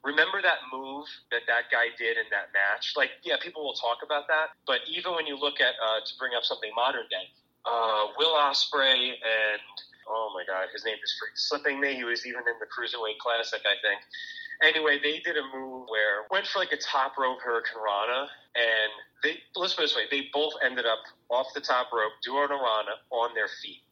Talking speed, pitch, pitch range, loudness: 215 wpm, 135 Hz, 115-150 Hz, -27 LUFS